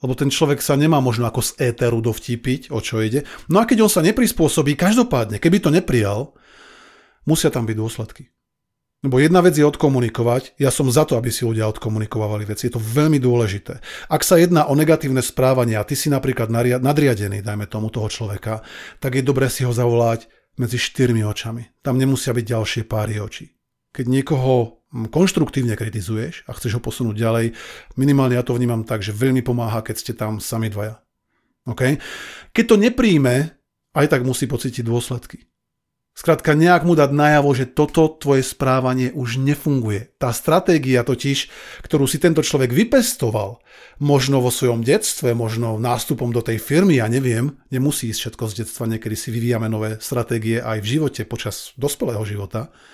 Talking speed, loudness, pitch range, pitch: 175 wpm, -19 LUFS, 115-145 Hz, 125 Hz